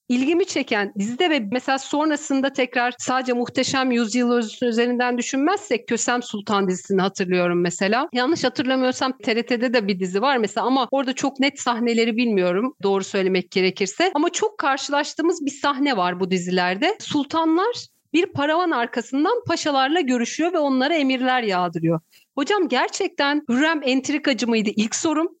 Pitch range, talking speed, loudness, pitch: 225-295 Hz, 140 wpm, -21 LUFS, 255 Hz